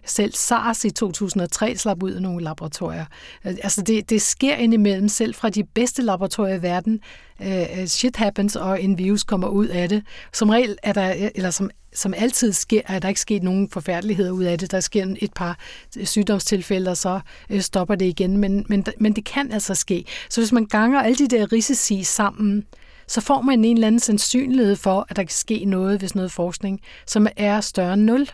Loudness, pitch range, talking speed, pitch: -20 LUFS, 190-220 Hz, 200 wpm, 205 Hz